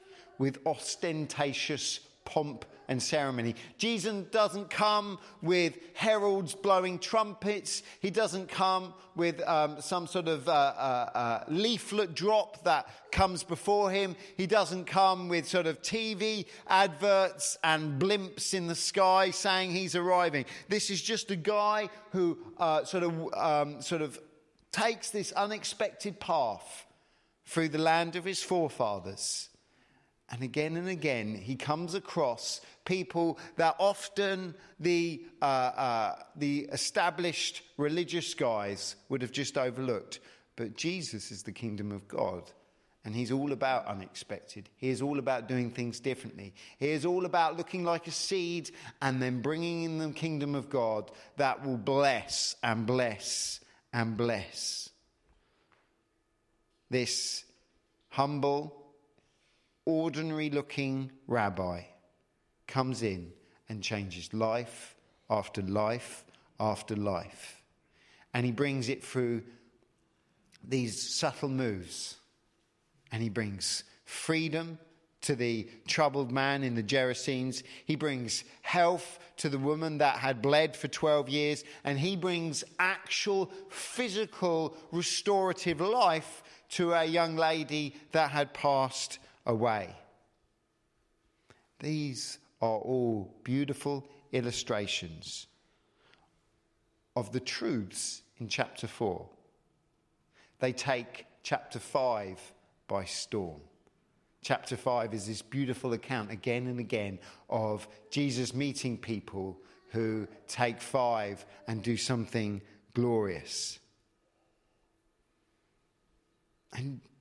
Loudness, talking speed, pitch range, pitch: -32 LUFS, 115 wpm, 120-175 Hz, 145 Hz